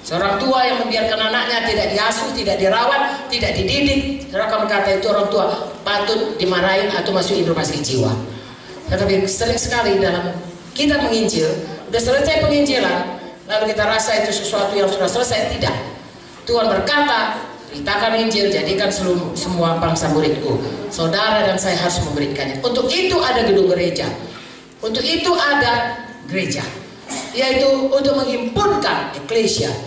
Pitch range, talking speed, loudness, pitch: 180-245 Hz, 135 wpm, -18 LUFS, 210 Hz